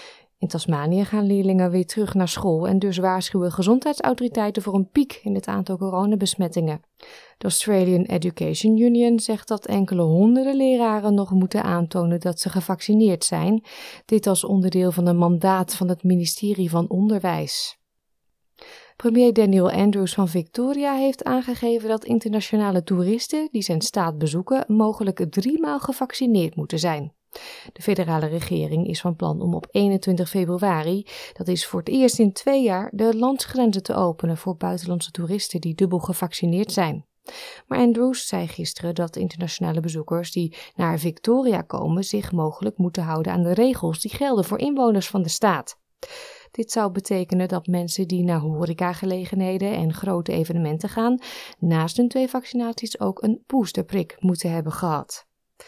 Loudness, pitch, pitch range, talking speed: -22 LUFS, 190 Hz, 175-225 Hz, 150 wpm